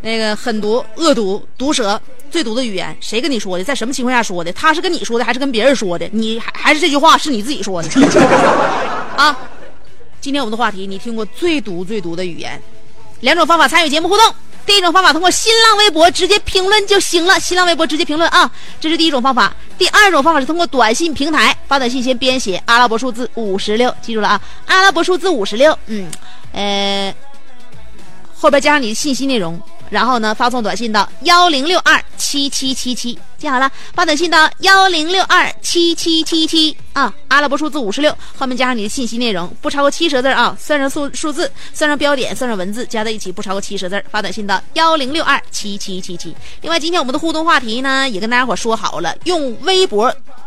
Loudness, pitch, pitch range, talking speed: -13 LUFS, 270 Hz, 220-325 Hz, 330 characters per minute